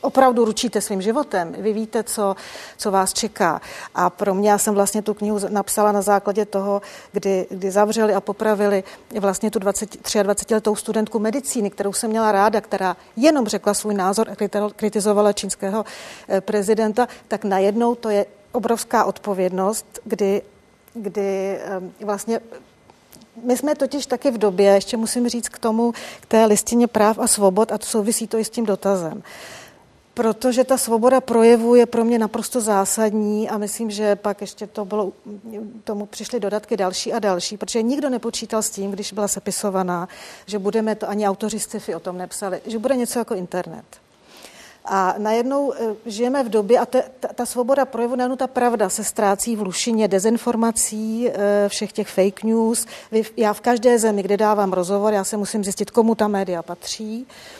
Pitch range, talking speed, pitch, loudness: 200-230 Hz, 165 wpm, 215 Hz, -20 LUFS